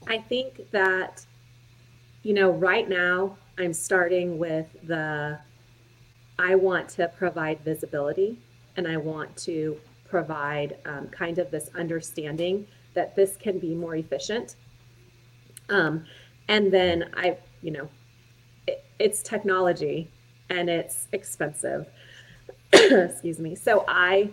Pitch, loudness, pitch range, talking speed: 160 Hz, -25 LUFS, 125-180 Hz, 120 wpm